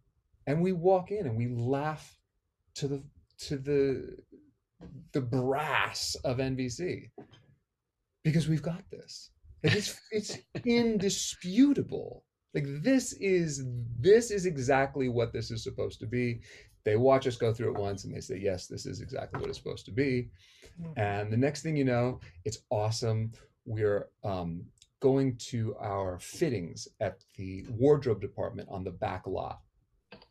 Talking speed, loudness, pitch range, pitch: 150 wpm, -31 LUFS, 110-150 Hz, 130 Hz